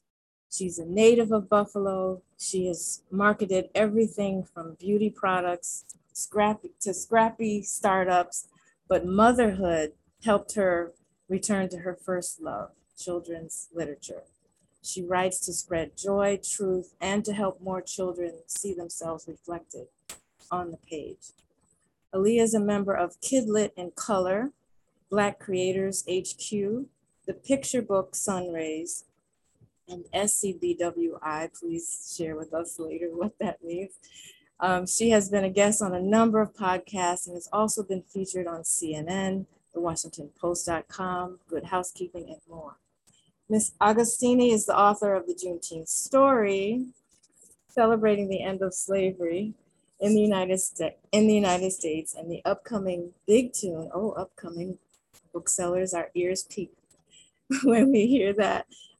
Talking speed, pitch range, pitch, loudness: 140 wpm, 175-210 Hz, 185 Hz, -27 LUFS